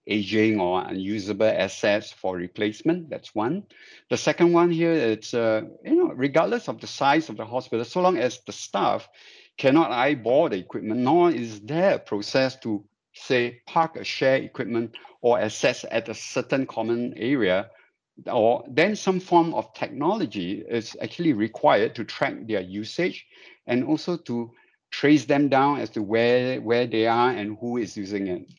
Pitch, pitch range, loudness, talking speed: 120 Hz, 110-150 Hz, -24 LUFS, 170 wpm